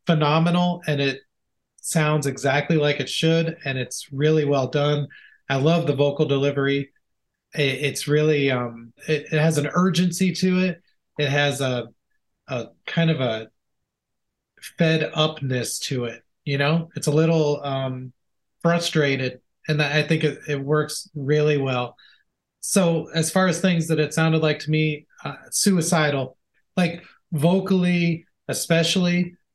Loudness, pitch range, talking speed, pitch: -22 LUFS, 140-165 Hz, 145 wpm, 150 Hz